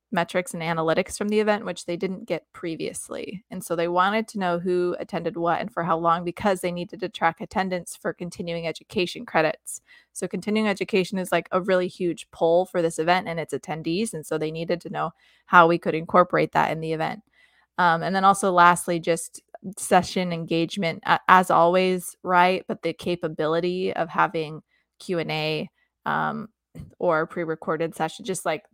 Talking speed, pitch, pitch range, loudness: 185 wpm, 175 Hz, 165-185 Hz, -24 LUFS